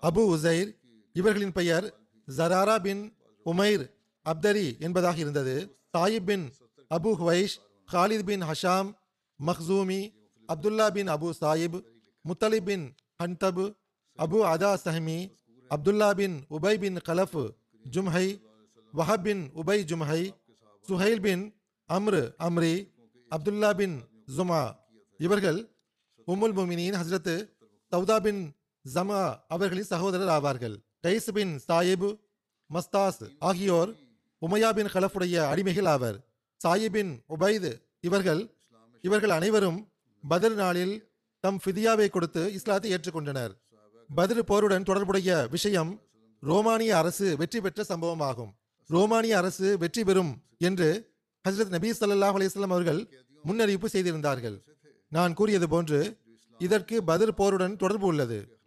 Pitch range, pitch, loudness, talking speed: 155-200 Hz, 180 Hz, -28 LUFS, 105 wpm